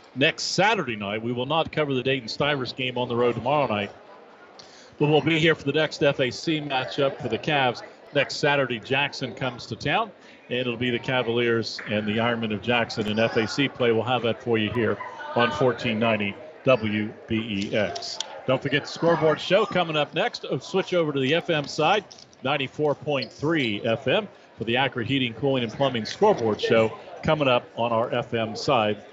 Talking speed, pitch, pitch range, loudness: 180 wpm, 125 Hz, 115-145 Hz, -24 LUFS